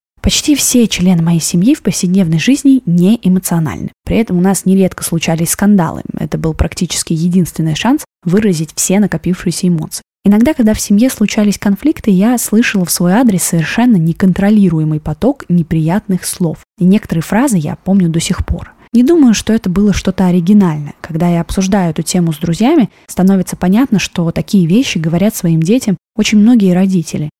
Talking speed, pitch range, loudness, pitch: 165 wpm, 170-215 Hz, -12 LUFS, 190 Hz